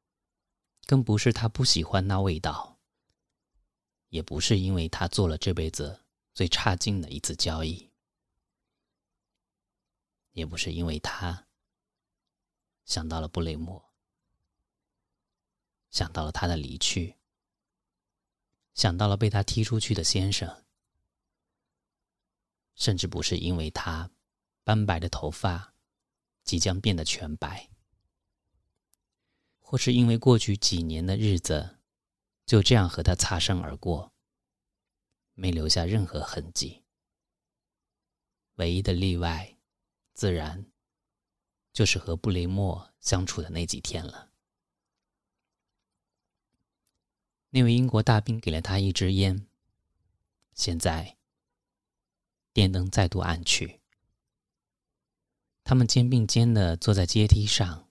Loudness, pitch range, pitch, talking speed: -27 LUFS, 85-100 Hz, 95 Hz, 160 characters per minute